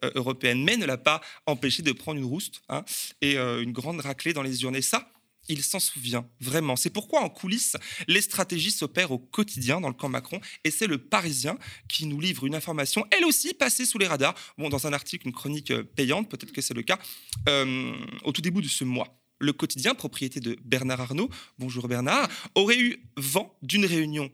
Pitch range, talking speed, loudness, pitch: 130-185 Hz, 205 wpm, -26 LUFS, 150 Hz